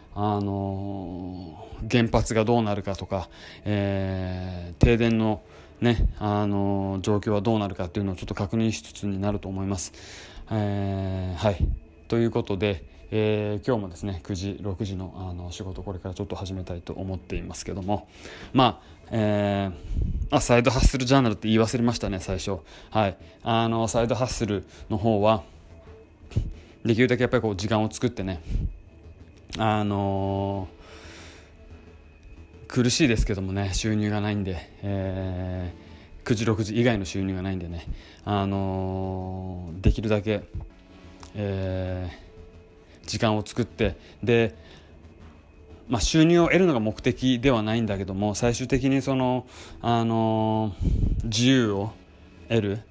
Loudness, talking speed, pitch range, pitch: -26 LUFS, 270 characters per minute, 90-110 Hz, 100 Hz